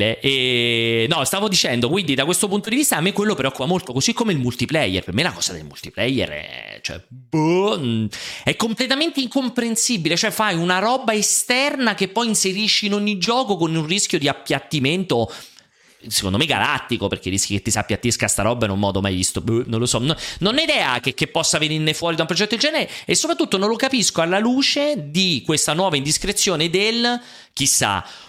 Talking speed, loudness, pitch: 205 wpm, -19 LUFS, 170 Hz